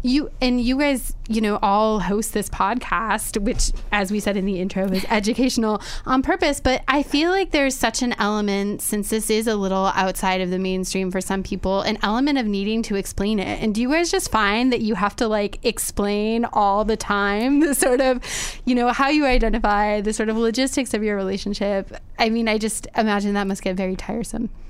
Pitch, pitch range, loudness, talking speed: 215 Hz, 200-245 Hz, -21 LUFS, 215 wpm